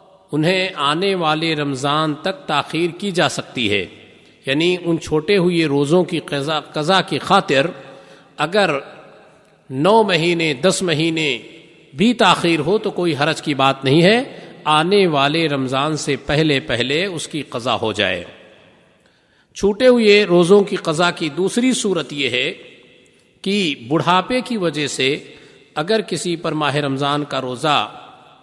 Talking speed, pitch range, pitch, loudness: 140 wpm, 145-190 Hz, 165 Hz, -17 LUFS